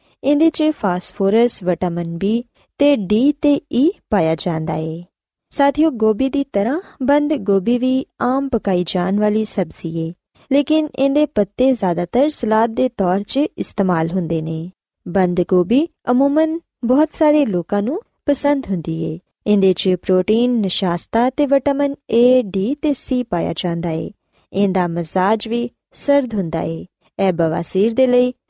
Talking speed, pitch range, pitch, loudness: 145 wpm, 180-280 Hz, 220 Hz, -18 LUFS